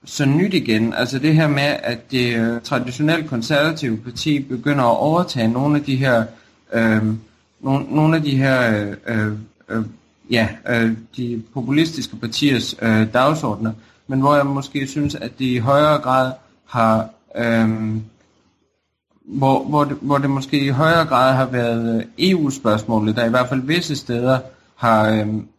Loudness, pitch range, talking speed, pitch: -18 LUFS, 115-145 Hz, 155 wpm, 125 Hz